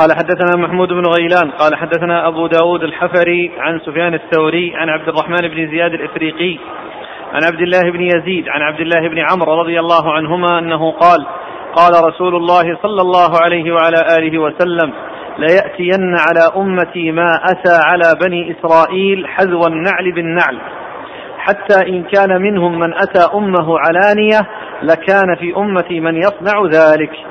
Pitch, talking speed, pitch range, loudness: 170 Hz, 150 wpm, 165-180 Hz, -12 LUFS